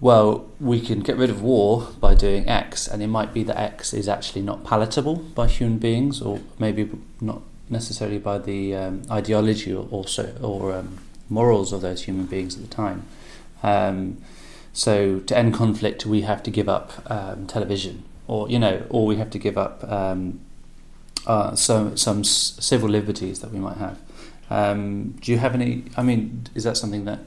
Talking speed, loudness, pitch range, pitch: 185 wpm, -23 LUFS, 100-115 Hz, 105 Hz